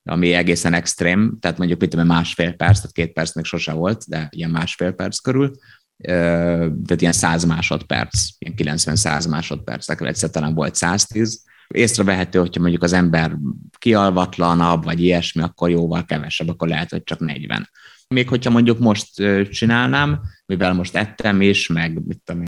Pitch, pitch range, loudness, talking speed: 85 Hz, 85-100 Hz, -18 LUFS, 160 wpm